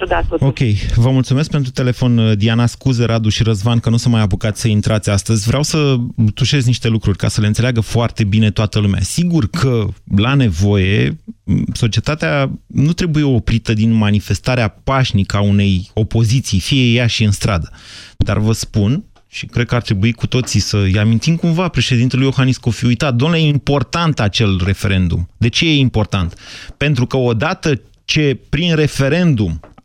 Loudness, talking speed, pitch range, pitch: -15 LUFS, 165 wpm, 105-135 Hz, 115 Hz